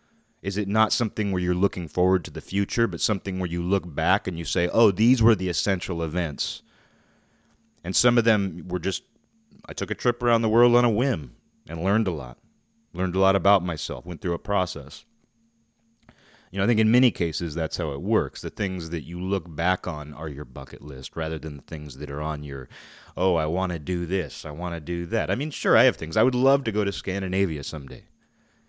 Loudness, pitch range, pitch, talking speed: -25 LUFS, 80-105 Hz, 90 Hz, 230 wpm